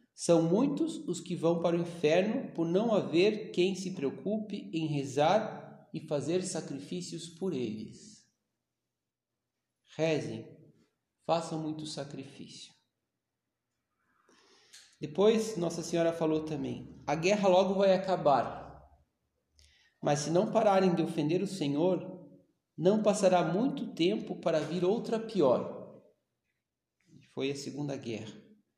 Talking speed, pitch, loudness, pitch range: 115 wpm, 170 Hz, -31 LUFS, 150-190 Hz